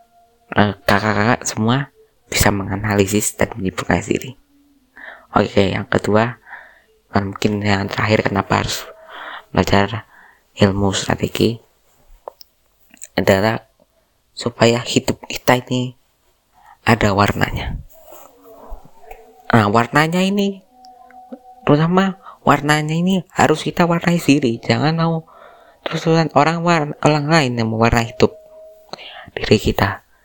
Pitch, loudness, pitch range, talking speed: 125 Hz, -17 LUFS, 105-170 Hz, 95 wpm